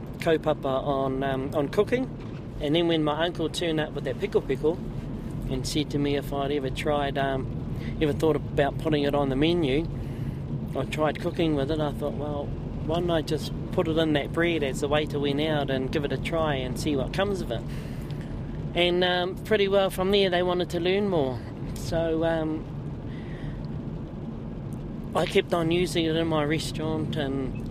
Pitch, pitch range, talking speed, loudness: 150 Hz, 140-170 Hz, 195 wpm, -27 LUFS